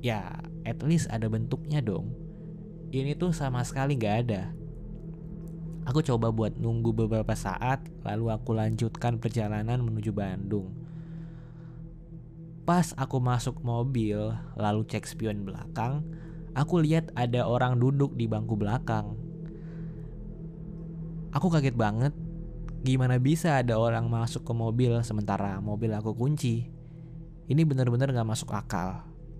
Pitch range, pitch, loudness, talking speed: 115-160 Hz, 135 Hz, -29 LUFS, 120 wpm